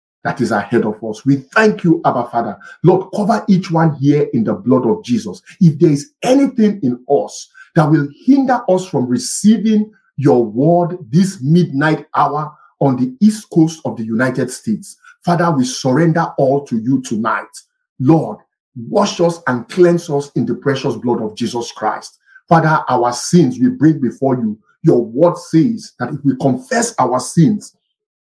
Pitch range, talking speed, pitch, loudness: 130-190 Hz, 170 wpm, 155 Hz, -15 LUFS